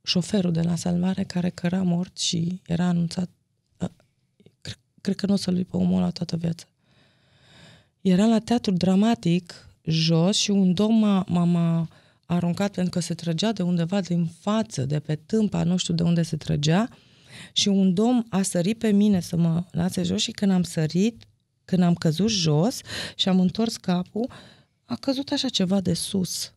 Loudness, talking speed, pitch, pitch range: -24 LUFS, 180 wpm, 180 Hz, 170-200 Hz